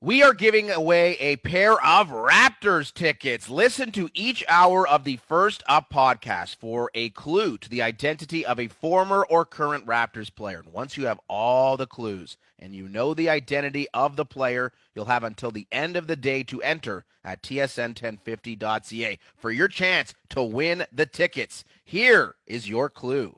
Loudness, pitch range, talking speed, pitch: -23 LUFS, 115-170 Hz, 175 wpm, 135 Hz